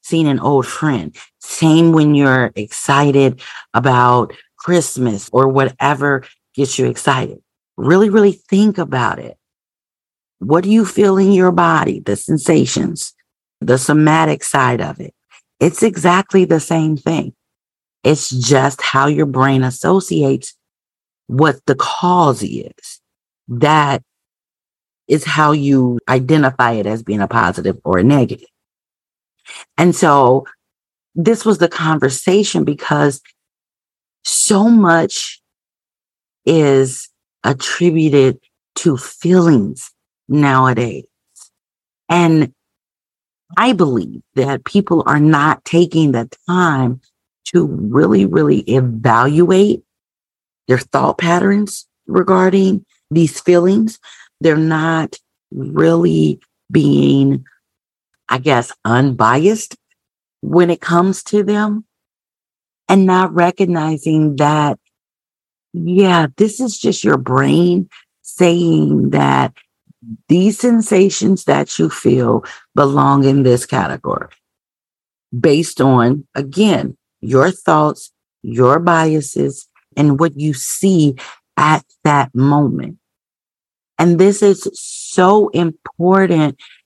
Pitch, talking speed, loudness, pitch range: 155 Hz, 100 wpm, -14 LUFS, 130-180 Hz